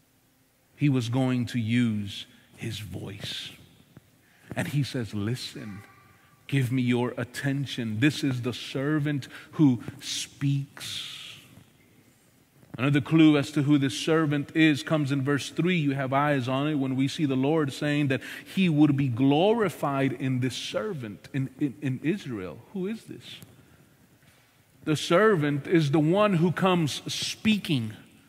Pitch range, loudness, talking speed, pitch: 130-150 Hz, -26 LUFS, 140 wpm, 140 Hz